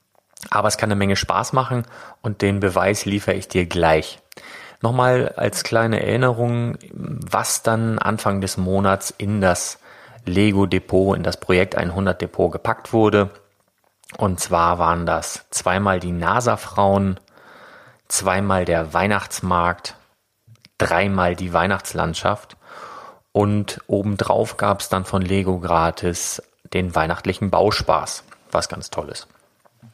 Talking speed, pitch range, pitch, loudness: 120 wpm, 90-105 Hz, 100 Hz, -20 LUFS